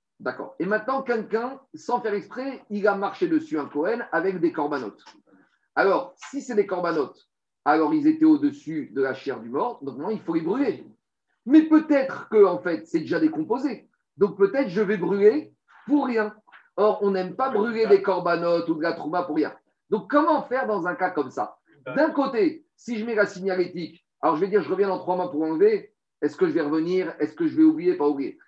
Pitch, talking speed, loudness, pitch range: 215 Hz, 215 wpm, -24 LUFS, 180-290 Hz